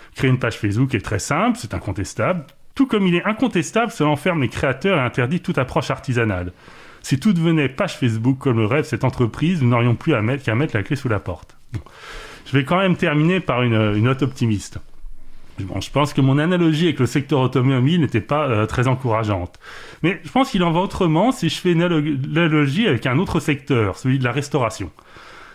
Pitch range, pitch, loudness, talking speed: 120-165 Hz, 140 Hz, -19 LUFS, 215 wpm